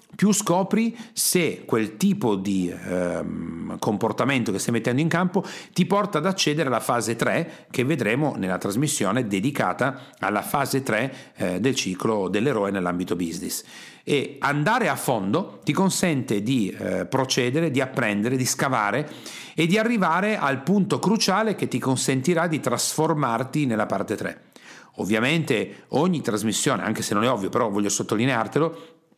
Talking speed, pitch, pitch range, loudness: 150 wpm, 150 Hz, 120-185 Hz, -23 LUFS